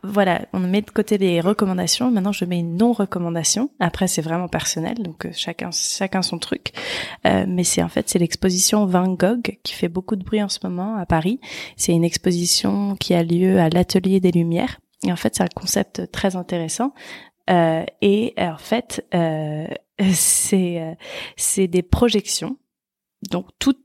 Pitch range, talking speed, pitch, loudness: 175-210 Hz, 175 wpm, 185 Hz, -20 LUFS